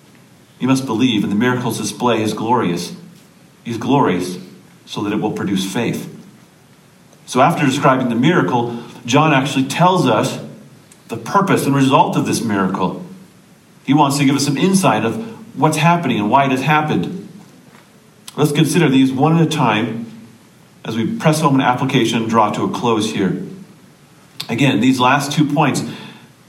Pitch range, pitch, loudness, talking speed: 120-155 Hz, 135 Hz, -16 LUFS, 165 wpm